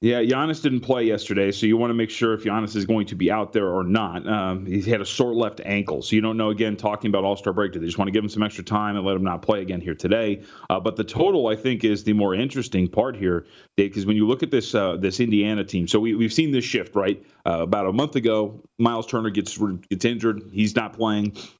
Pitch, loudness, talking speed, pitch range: 105 Hz, -23 LUFS, 270 wpm, 100-115 Hz